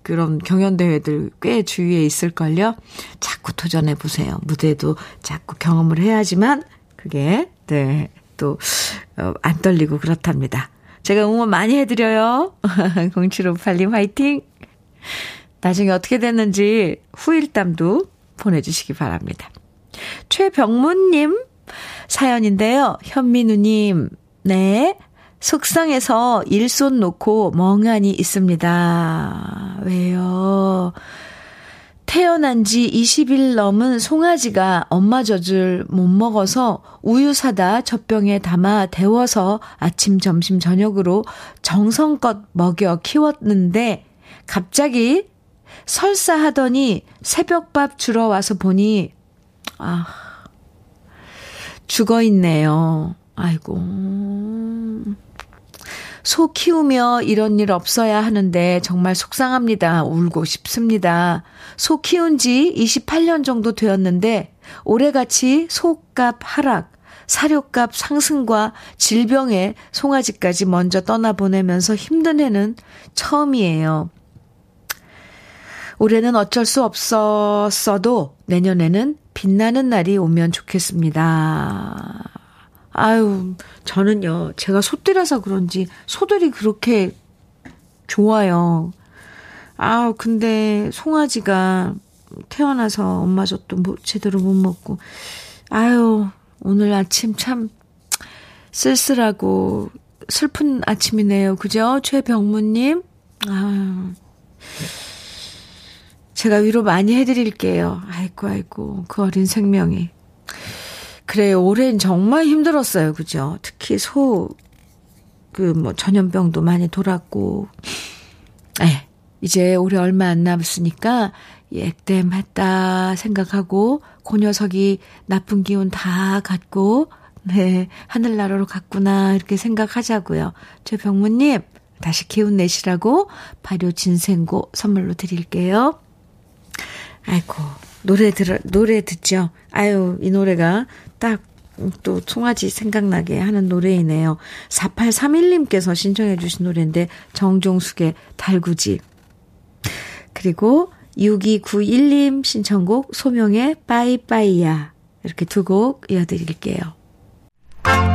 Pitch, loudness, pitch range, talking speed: 200 Hz, -17 LUFS, 180-230 Hz, 215 characters per minute